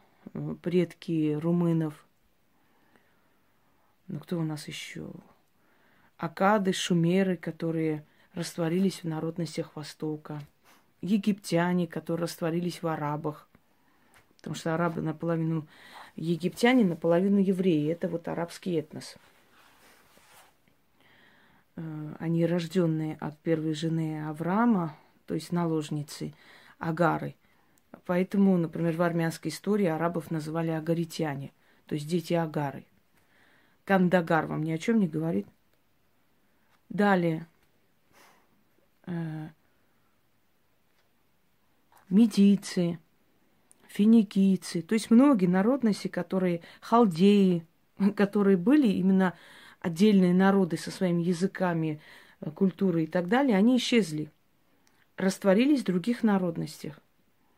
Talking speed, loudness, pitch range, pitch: 90 wpm, -27 LUFS, 160-195 Hz, 170 Hz